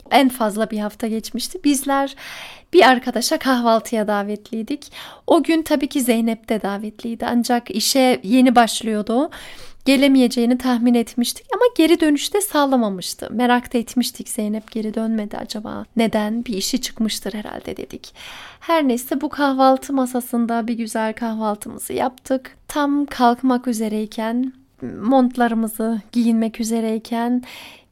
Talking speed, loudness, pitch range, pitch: 120 wpm, -19 LUFS, 225-265 Hz, 240 Hz